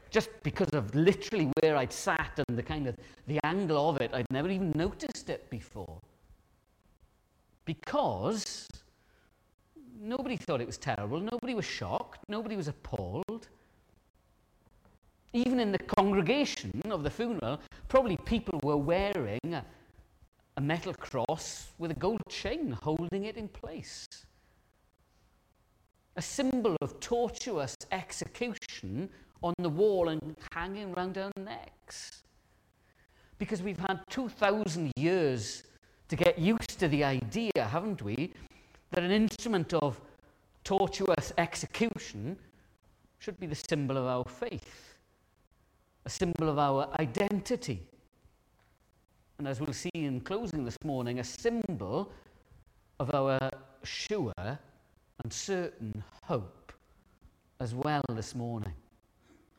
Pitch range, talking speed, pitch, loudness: 130-200 Hz, 120 wpm, 165 Hz, -33 LUFS